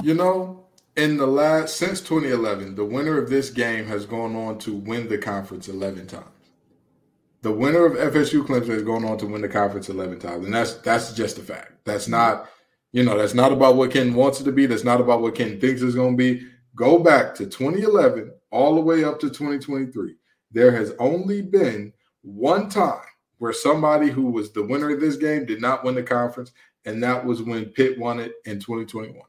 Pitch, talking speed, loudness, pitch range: 125 Hz, 220 wpm, -21 LUFS, 110-145 Hz